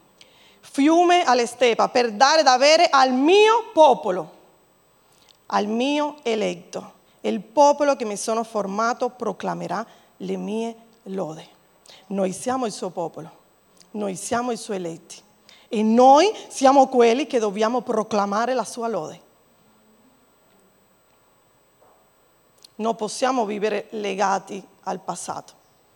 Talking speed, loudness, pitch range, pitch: 110 wpm, -20 LUFS, 205-260 Hz, 230 Hz